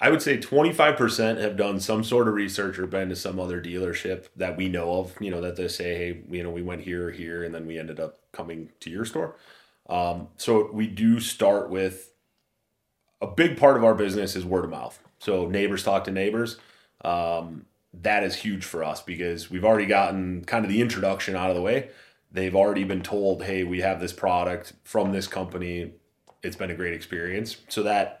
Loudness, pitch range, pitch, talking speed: -26 LUFS, 90-100 Hz, 95 Hz, 210 wpm